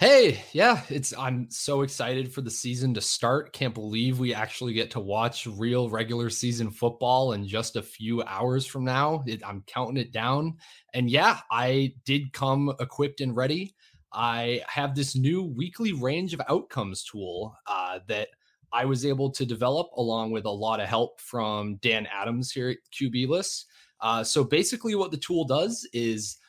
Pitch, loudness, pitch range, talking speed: 125 Hz, -27 LUFS, 115-140 Hz, 180 wpm